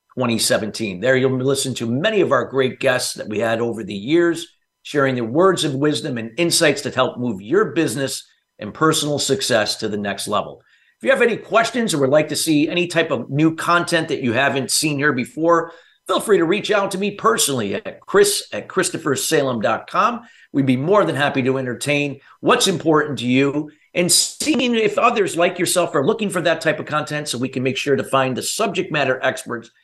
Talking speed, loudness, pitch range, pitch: 205 wpm, -19 LUFS, 130-170 Hz, 150 Hz